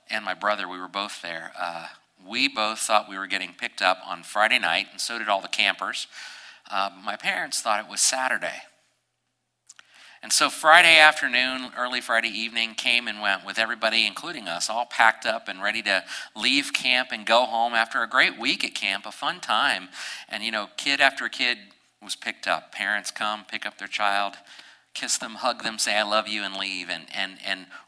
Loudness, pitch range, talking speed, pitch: -23 LUFS, 100-120 Hz, 200 wpm, 110 Hz